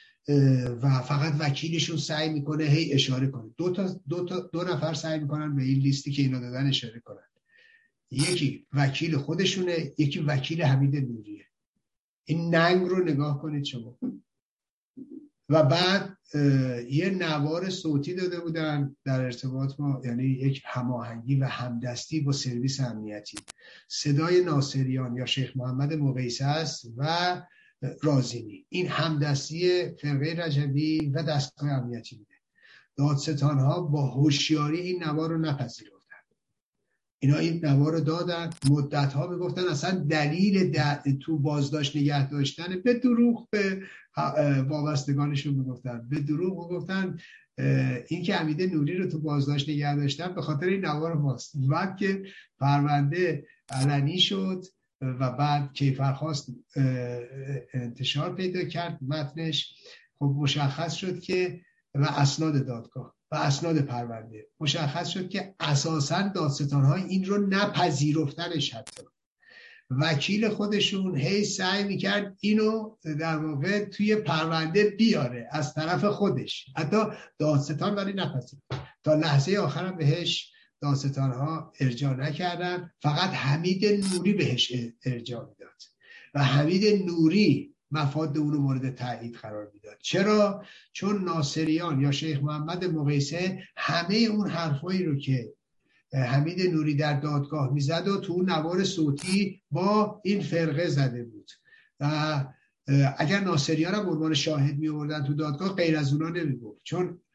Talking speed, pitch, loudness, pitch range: 130 wpm, 155 Hz, -27 LUFS, 140-180 Hz